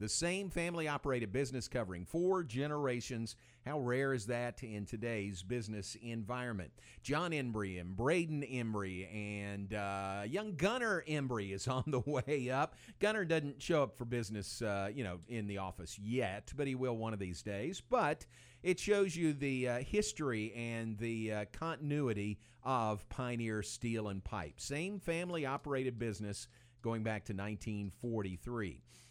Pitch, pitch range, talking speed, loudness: 120 Hz, 105-140 Hz, 155 wpm, -39 LUFS